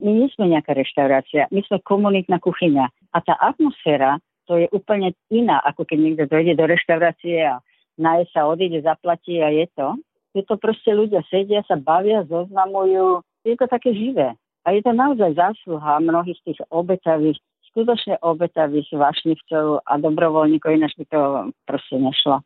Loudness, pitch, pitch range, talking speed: -19 LUFS, 170 Hz, 155-195 Hz, 165 wpm